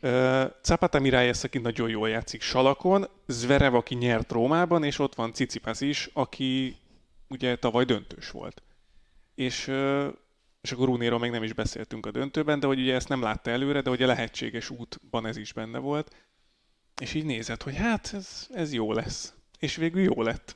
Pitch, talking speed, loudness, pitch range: 130 Hz, 175 wpm, -27 LUFS, 115-145 Hz